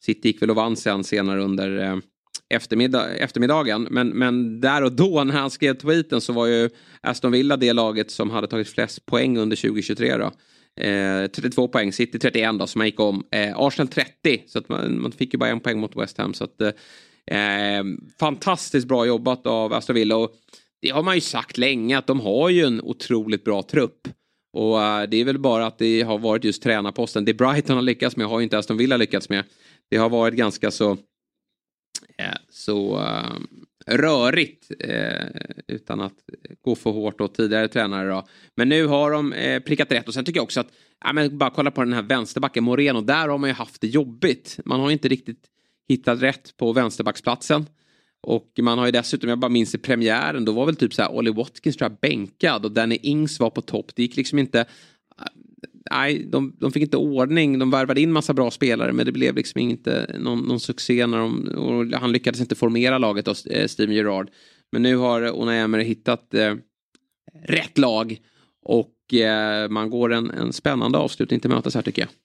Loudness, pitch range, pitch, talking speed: -22 LUFS, 110-130 Hz, 115 Hz, 200 wpm